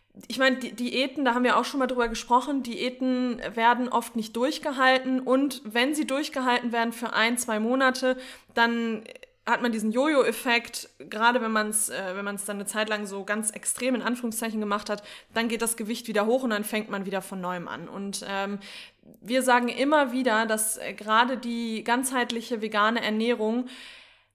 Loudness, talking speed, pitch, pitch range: -26 LUFS, 180 wpm, 235 Hz, 220-255 Hz